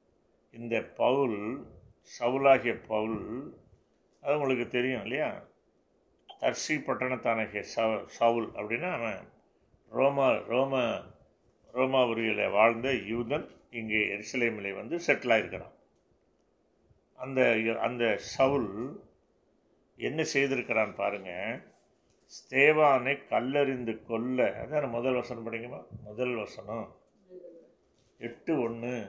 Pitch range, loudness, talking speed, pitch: 115-135 Hz, -30 LUFS, 85 wpm, 120 Hz